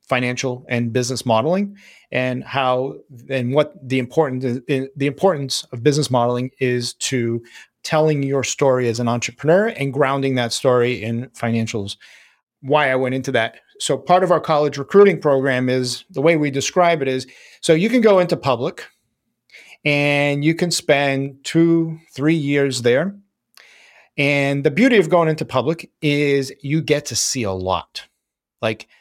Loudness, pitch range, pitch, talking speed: -19 LUFS, 125-160 Hz, 140 Hz, 160 wpm